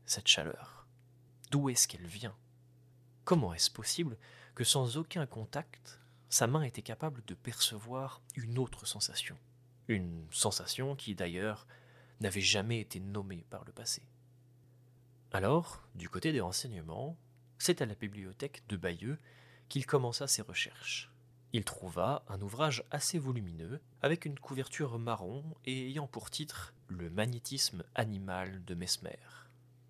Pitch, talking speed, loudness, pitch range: 125 Hz, 135 wpm, -36 LUFS, 105-135 Hz